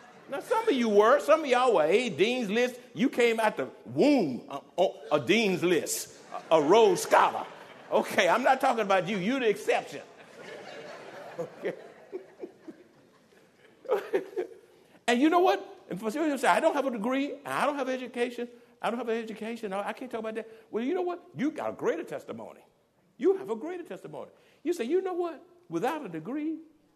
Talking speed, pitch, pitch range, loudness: 200 wpm, 265 Hz, 230-355 Hz, -28 LUFS